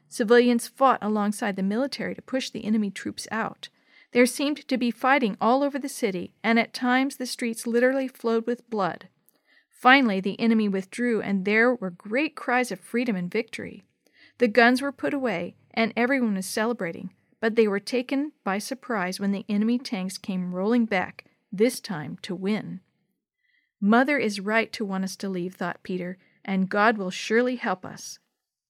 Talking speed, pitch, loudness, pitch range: 175 wpm, 225 Hz, -25 LUFS, 195-250 Hz